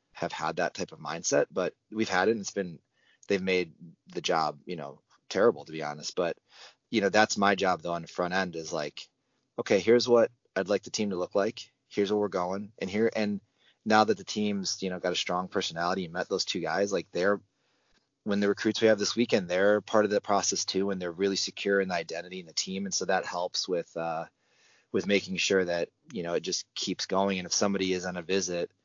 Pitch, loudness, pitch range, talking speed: 95 Hz, -29 LUFS, 90-105 Hz, 240 wpm